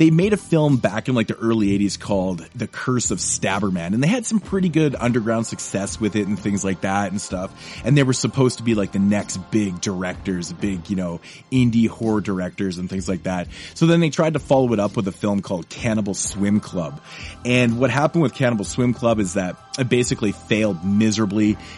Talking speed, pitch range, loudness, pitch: 220 wpm, 100-125 Hz, -21 LUFS, 110 Hz